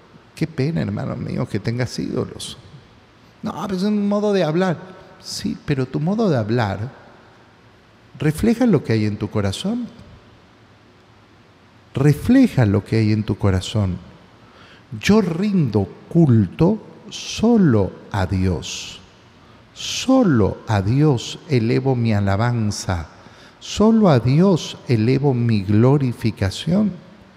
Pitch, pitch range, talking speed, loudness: 120 Hz, 105-175 Hz, 115 wpm, -19 LUFS